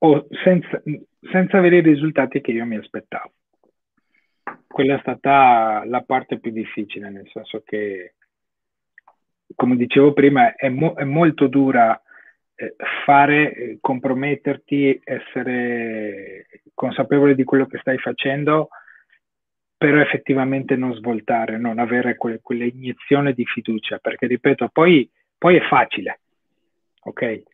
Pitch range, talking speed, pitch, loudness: 120-145 Hz, 120 wpm, 135 Hz, -18 LUFS